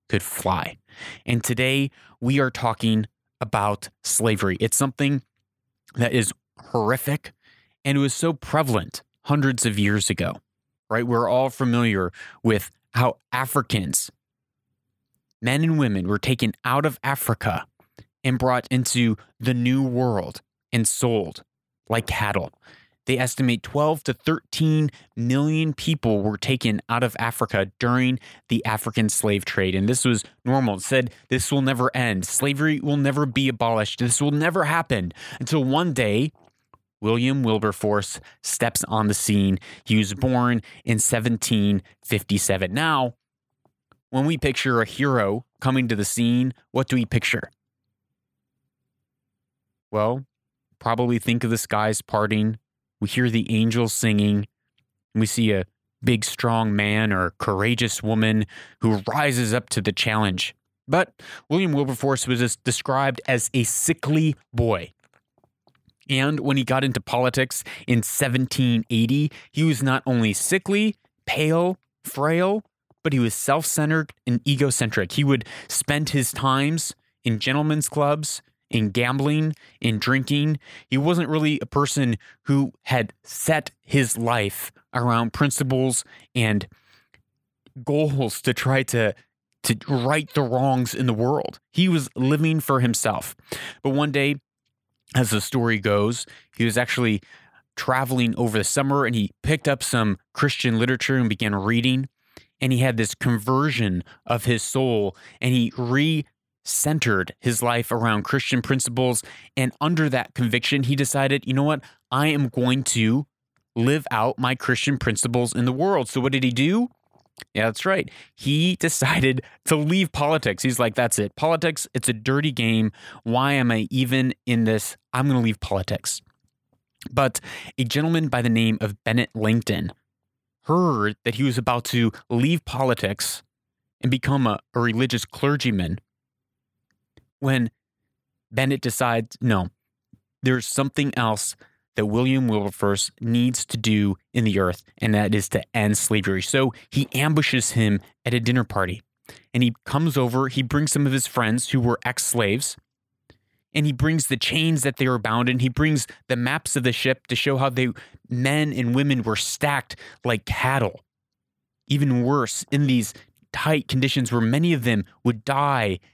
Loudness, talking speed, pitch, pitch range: -22 LUFS, 150 wpm, 125 Hz, 110-140 Hz